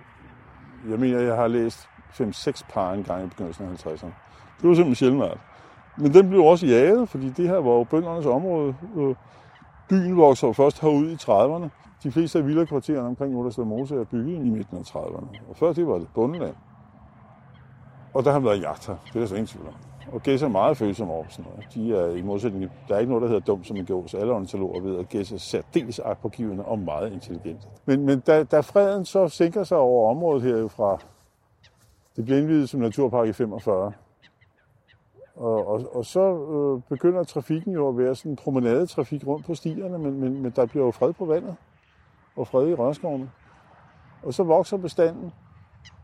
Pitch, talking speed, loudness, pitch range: 130 Hz, 205 wpm, -23 LUFS, 110-155 Hz